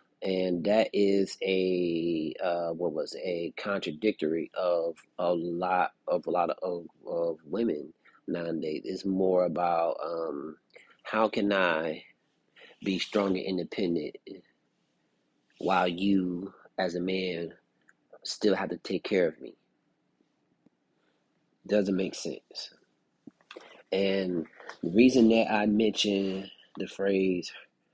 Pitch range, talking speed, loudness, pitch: 85-100 Hz, 120 wpm, -29 LUFS, 95 Hz